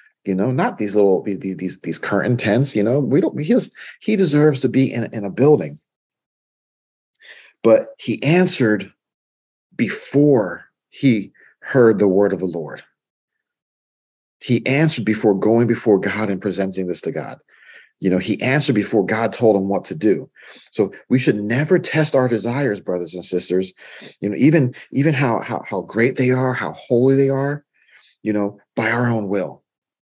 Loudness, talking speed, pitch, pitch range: -18 LUFS, 170 wpm, 115 Hz, 100-135 Hz